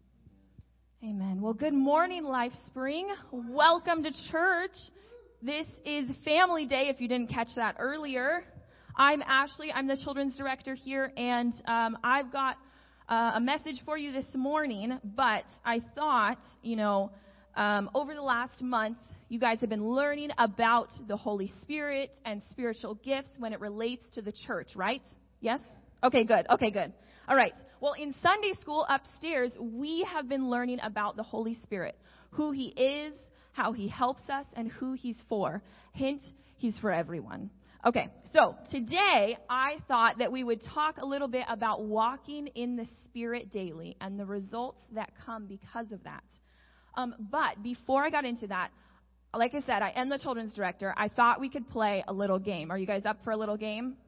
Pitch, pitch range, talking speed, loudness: 245 Hz, 220-275 Hz, 175 wpm, -31 LUFS